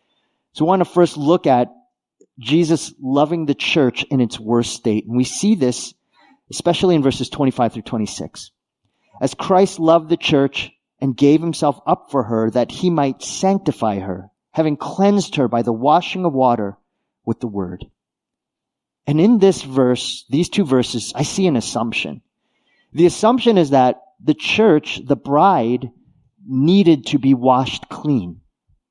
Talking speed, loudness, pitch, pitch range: 160 wpm, -17 LUFS, 140 Hz, 120-170 Hz